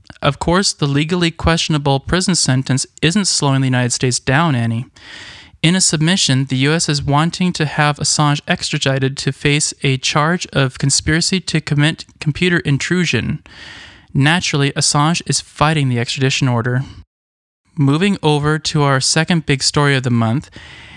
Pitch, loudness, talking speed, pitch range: 145 Hz, -15 LUFS, 150 wpm, 135-160 Hz